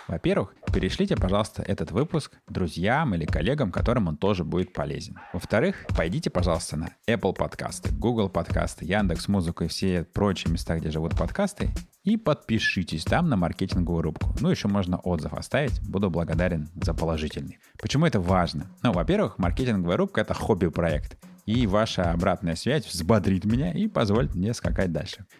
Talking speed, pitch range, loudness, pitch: 155 wpm, 85-105 Hz, -26 LUFS, 95 Hz